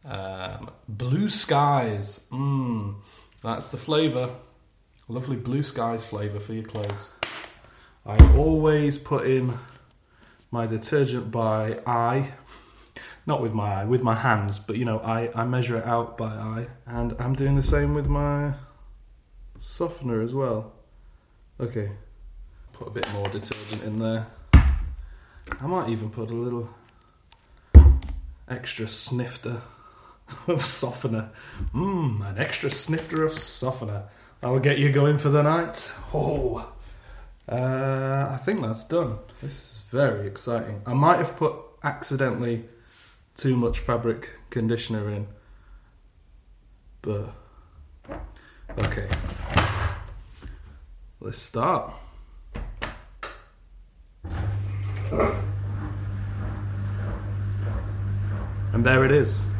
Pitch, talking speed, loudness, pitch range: 115 Hz, 110 wpm, -25 LUFS, 100-130 Hz